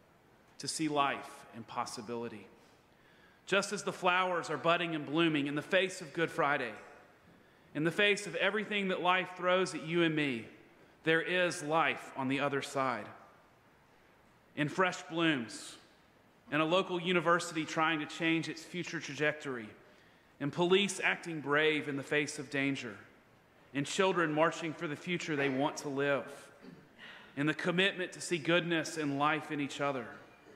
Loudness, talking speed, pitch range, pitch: -33 LUFS, 160 wpm, 140-175 Hz, 155 Hz